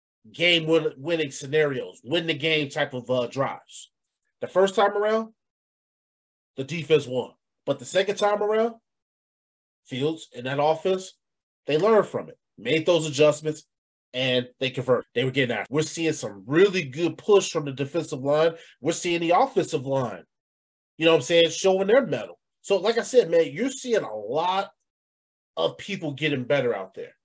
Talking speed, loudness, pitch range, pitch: 170 wpm, -24 LUFS, 135-185 Hz, 155 Hz